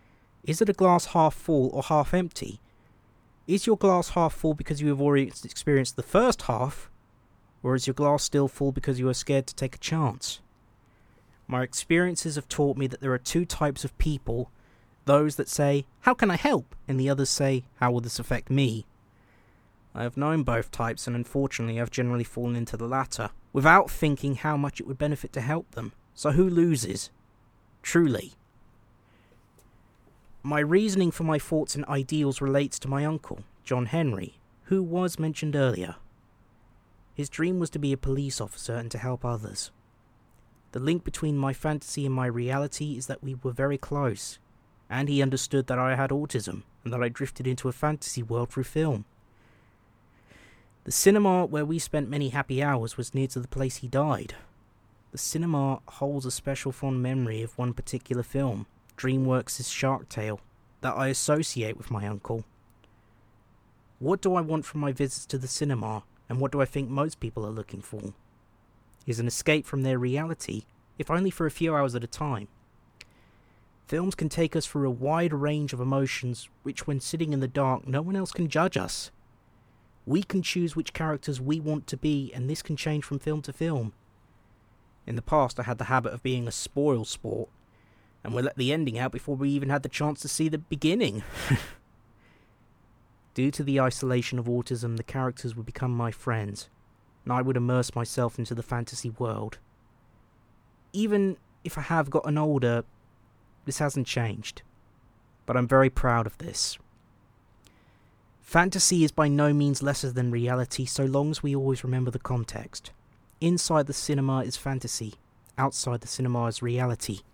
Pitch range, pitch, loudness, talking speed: 115-145 Hz, 130 Hz, -28 LUFS, 180 wpm